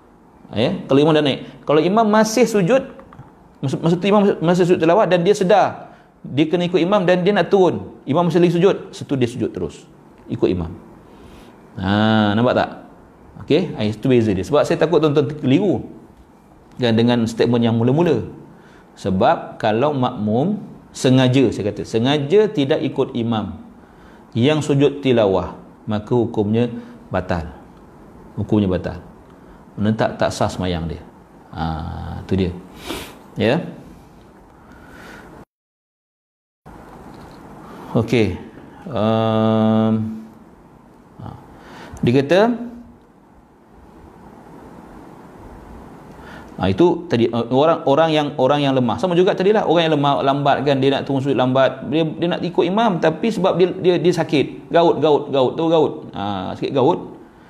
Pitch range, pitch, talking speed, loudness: 110-175 Hz, 135 Hz, 135 wpm, -18 LUFS